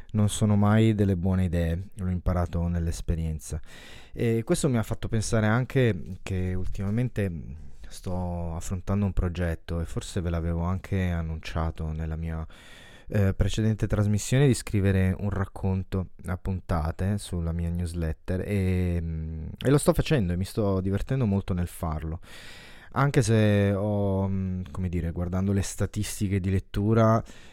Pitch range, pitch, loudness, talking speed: 85-105 Hz, 95 Hz, -27 LUFS, 140 wpm